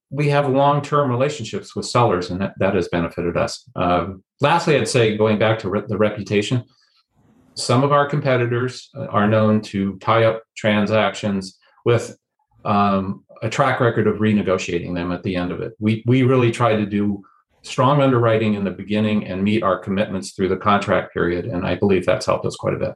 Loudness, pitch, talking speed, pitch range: -19 LUFS, 110 Hz, 195 wpm, 100-125 Hz